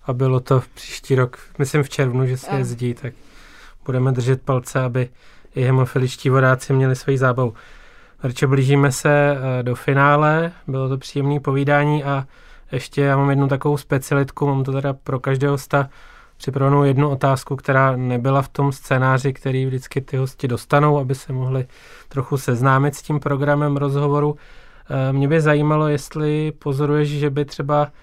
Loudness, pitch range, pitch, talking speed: -19 LUFS, 130-145 Hz, 140 Hz, 160 wpm